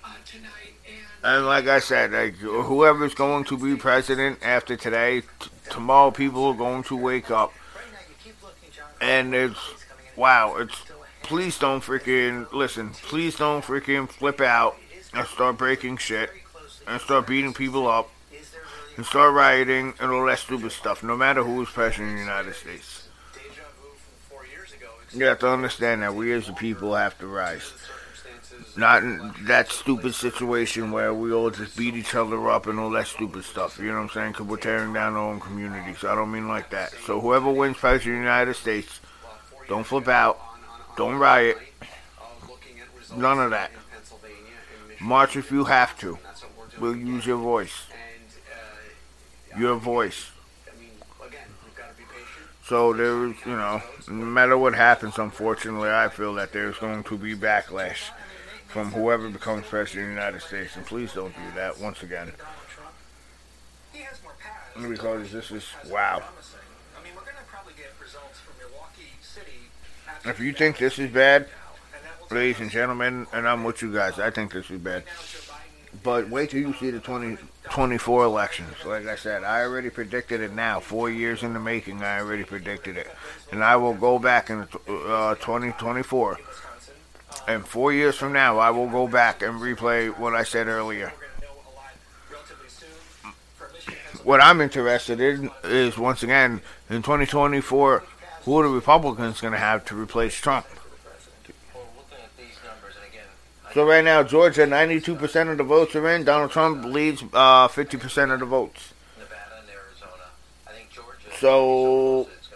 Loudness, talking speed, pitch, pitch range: -22 LUFS, 150 wpm, 120 Hz, 110-135 Hz